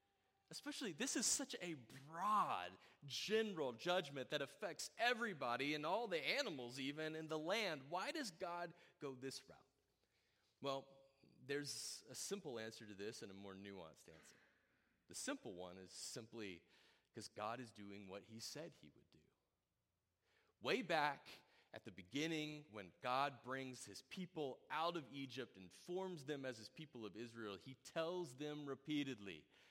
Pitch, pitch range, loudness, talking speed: 140 Hz, 115-170 Hz, -46 LUFS, 155 wpm